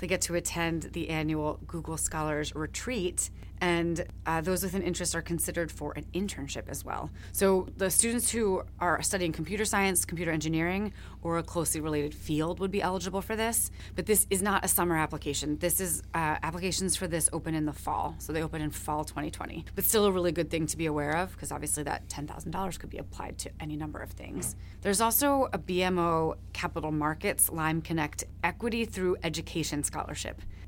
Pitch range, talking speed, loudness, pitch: 155-185 Hz, 195 wpm, -30 LUFS, 170 Hz